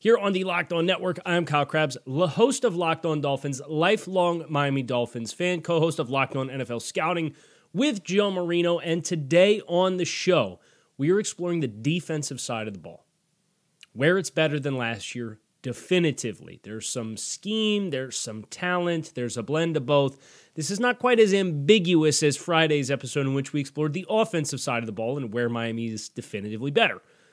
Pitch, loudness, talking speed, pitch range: 155 Hz, -25 LUFS, 190 wpm, 130-180 Hz